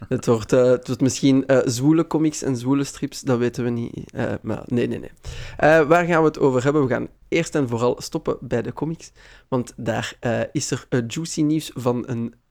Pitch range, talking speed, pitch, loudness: 125-150 Hz, 225 wpm, 135 Hz, -21 LUFS